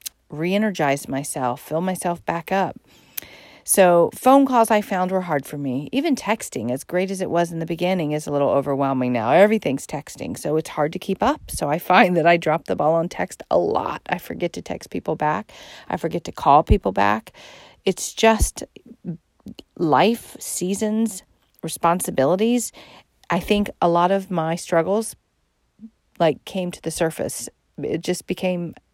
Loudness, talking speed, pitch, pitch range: -21 LUFS, 170 wpm, 175 Hz, 160-200 Hz